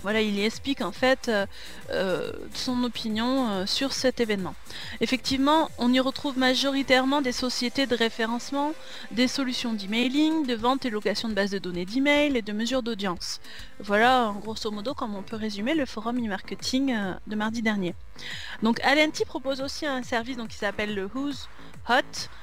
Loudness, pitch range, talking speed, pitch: -26 LUFS, 215-270 Hz, 175 wpm, 245 Hz